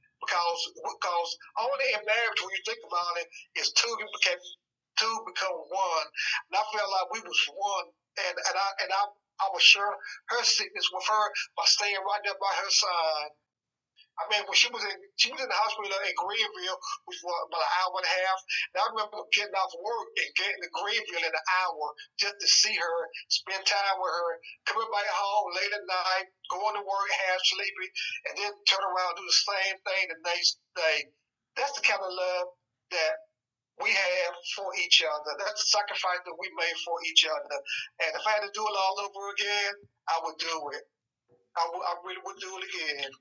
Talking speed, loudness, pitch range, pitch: 205 wpm, -28 LUFS, 175-210 Hz, 195 Hz